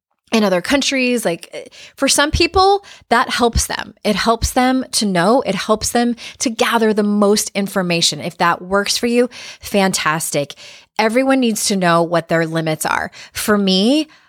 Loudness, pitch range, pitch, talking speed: -16 LUFS, 185-250 Hz, 215 Hz, 165 wpm